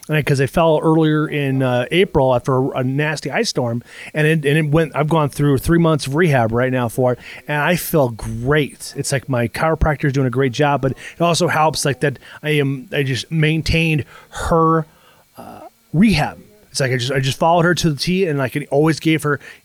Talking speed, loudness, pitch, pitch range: 225 wpm, -17 LUFS, 145 Hz, 135-160 Hz